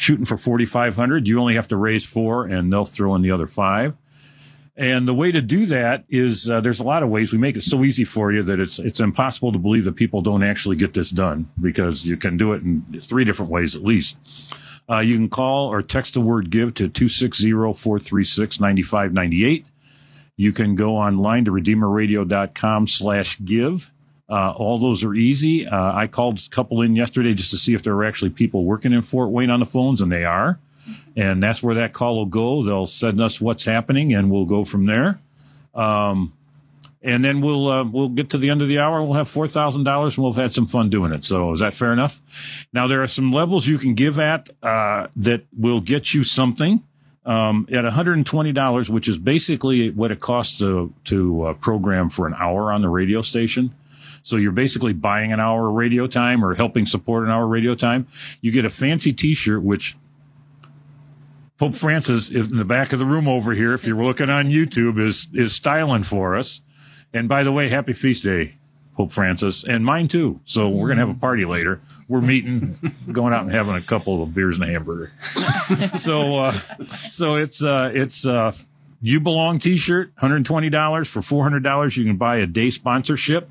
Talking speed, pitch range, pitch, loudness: 205 wpm, 105-140 Hz, 120 Hz, -19 LUFS